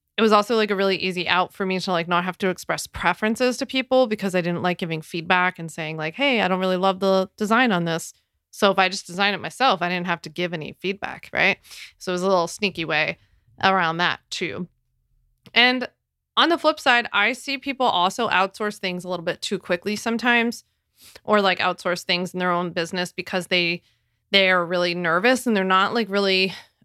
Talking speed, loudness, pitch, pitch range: 220 wpm, -21 LUFS, 185 Hz, 175-210 Hz